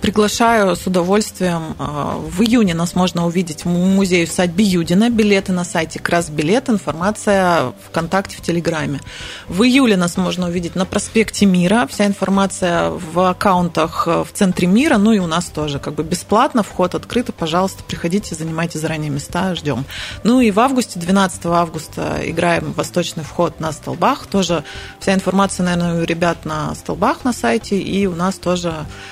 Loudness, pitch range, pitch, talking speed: -17 LUFS, 170-205 Hz, 180 Hz, 160 wpm